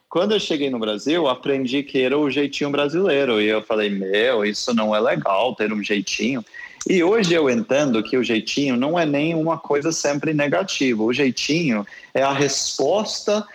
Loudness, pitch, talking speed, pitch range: -20 LUFS, 135 Hz, 180 wpm, 110-145 Hz